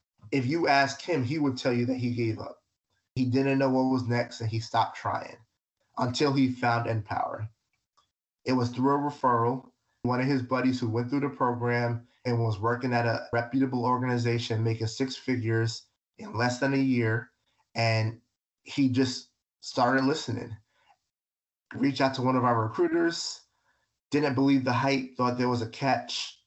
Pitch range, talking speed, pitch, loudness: 115-135 Hz, 175 wpm, 125 Hz, -28 LUFS